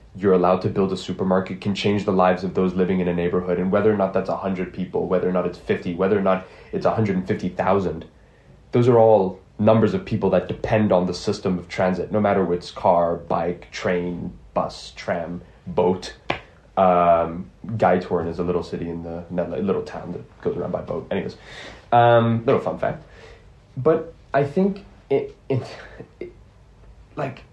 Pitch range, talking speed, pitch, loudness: 90-105 Hz, 185 wpm, 95 Hz, -22 LUFS